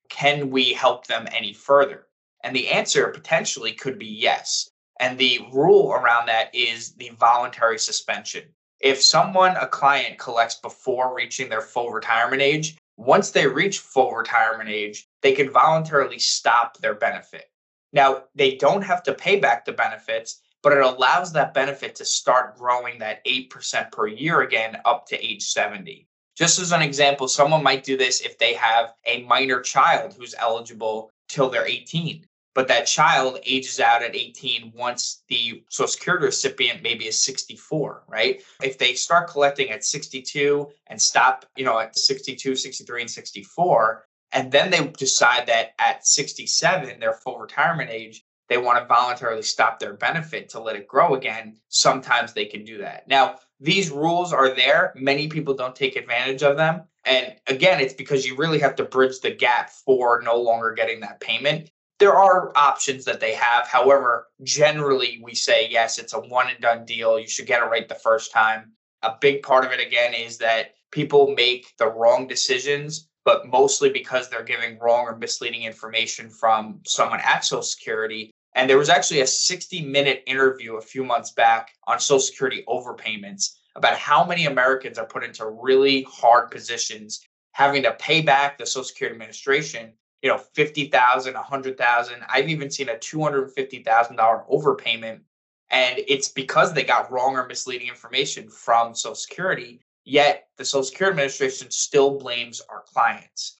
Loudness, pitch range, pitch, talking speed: -21 LUFS, 115-150 Hz, 130 Hz, 175 wpm